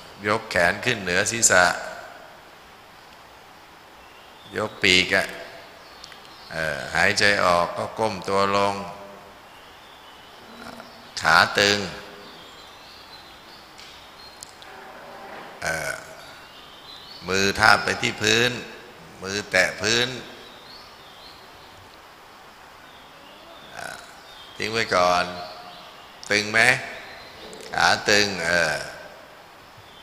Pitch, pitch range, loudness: 100 Hz, 90-110 Hz, -21 LUFS